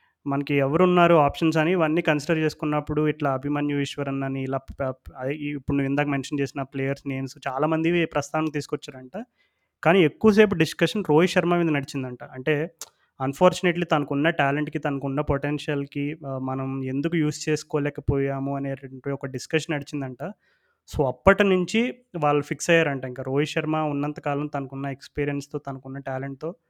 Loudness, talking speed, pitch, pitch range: -24 LUFS, 130 wpm, 145 Hz, 140-160 Hz